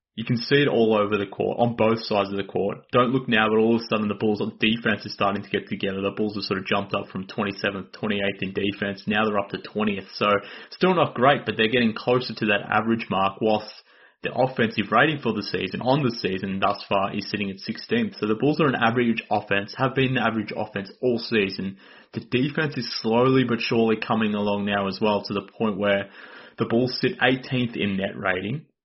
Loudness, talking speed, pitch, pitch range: -24 LUFS, 235 wpm, 110 Hz, 100-120 Hz